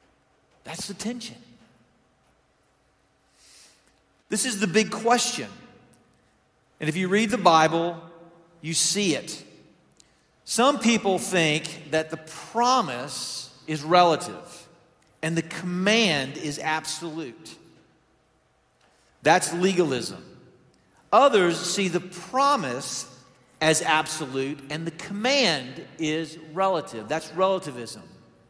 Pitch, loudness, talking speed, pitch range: 170 Hz, -24 LUFS, 95 wpm, 155-200 Hz